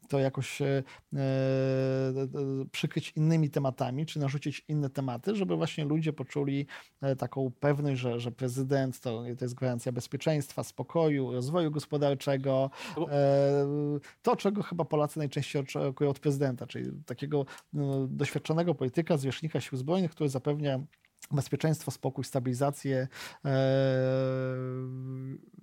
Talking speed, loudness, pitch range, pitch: 120 wpm, -31 LUFS, 130-150 Hz, 140 Hz